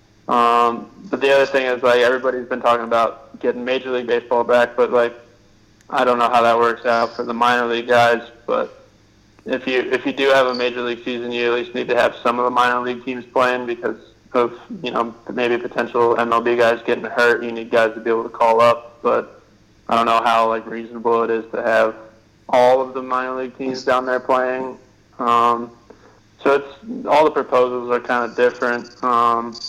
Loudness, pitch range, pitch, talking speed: -18 LUFS, 115-125 Hz, 120 Hz, 210 wpm